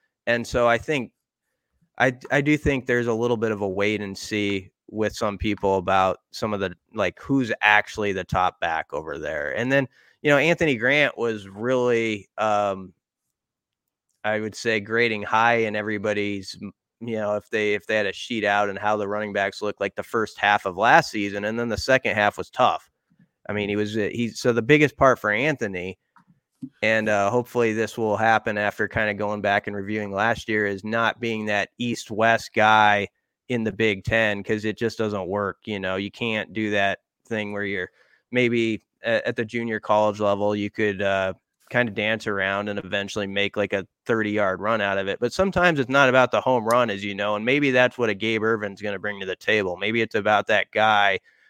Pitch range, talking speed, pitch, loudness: 100-115 Hz, 210 wpm, 105 Hz, -23 LUFS